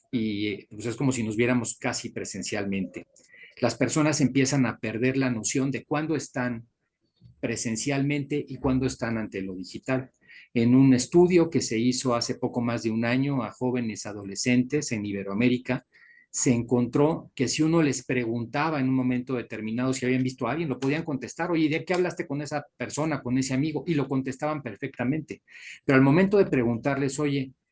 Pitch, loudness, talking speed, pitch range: 130 Hz, -26 LUFS, 180 wpm, 120-145 Hz